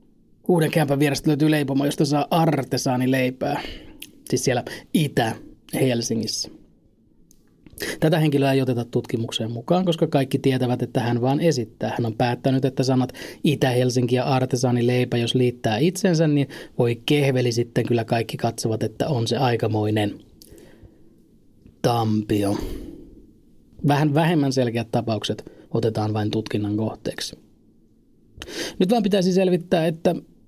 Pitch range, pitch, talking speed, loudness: 115-150 Hz, 130 Hz, 120 wpm, -22 LUFS